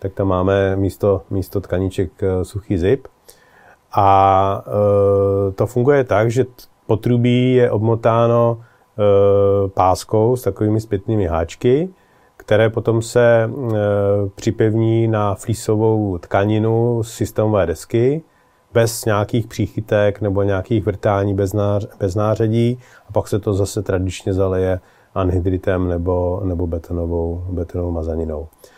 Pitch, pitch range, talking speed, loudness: 105 Hz, 95-115 Hz, 120 wpm, -18 LUFS